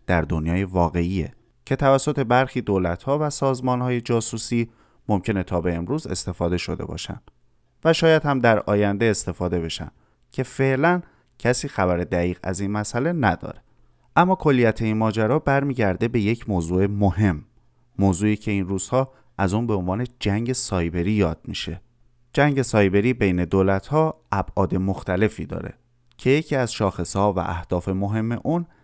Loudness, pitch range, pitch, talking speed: -22 LUFS, 95-125 Hz, 110 Hz, 145 wpm